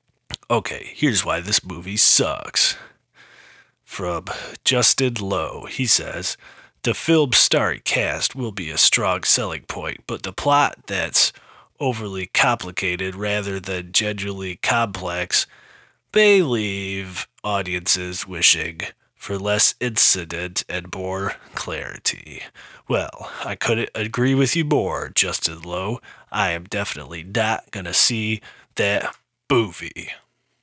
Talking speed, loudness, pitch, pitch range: 115 wpm, -20 LUFS, 100 Hz, 90-115 Hz